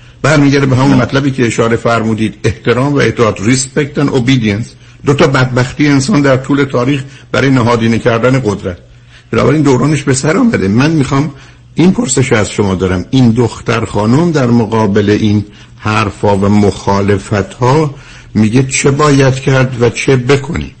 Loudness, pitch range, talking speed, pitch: -11 LUFS, 110-135 Hz, 160 wpm, 125 Hz